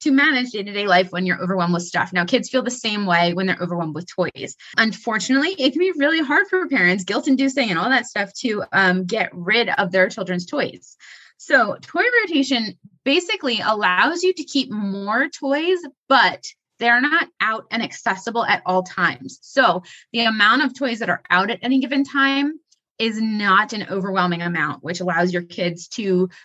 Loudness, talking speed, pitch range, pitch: -19 LUFS, 195 wpm, 185-275 Hz, 220 Hz